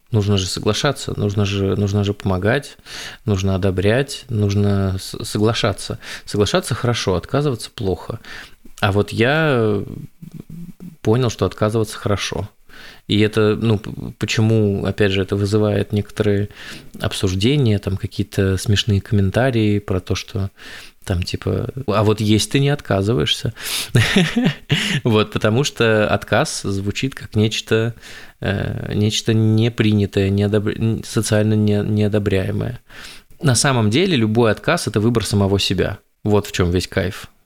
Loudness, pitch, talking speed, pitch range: -19 LUFS, 105 Hz, 115 wpm, 100-120 Hz